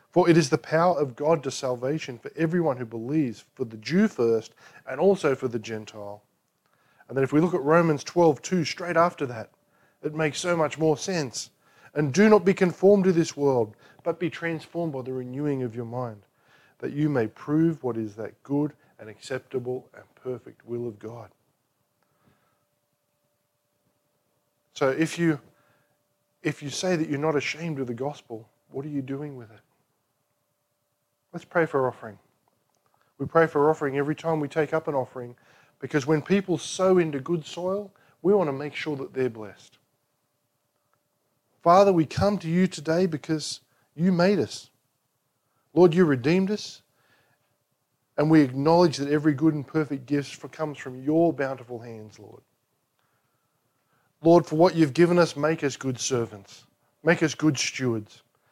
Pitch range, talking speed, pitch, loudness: 125-160 Hz, 170 wpm, 145 Hz, -25 LUFS